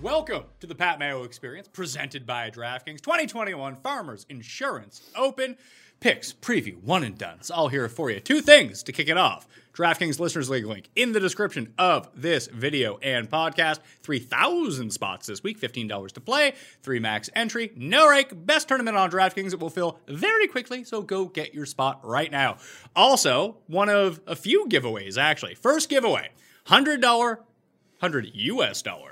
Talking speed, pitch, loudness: 180 wpm, 180 Hz, -24 LUFS